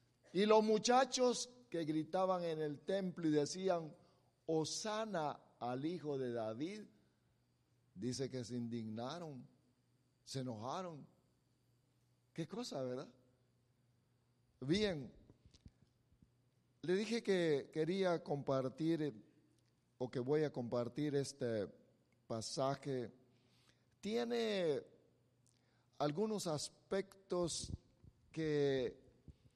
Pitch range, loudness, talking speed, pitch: 125-180 Hz, -40 LUFS, 85 wpm, 140 Hz